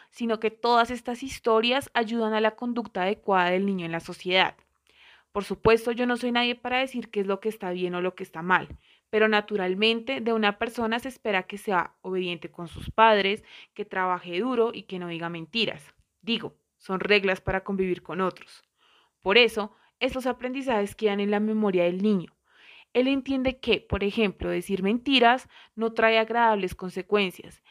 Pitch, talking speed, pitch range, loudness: 210 Hz, 180 wpm, 185-235 Hz, -26 LUFS